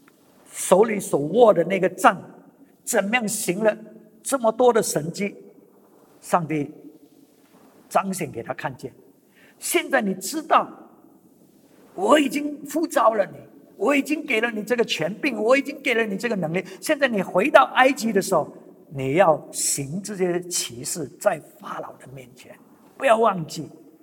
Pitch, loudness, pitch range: 205 Hz, -22 LUFS, 165-250 Hz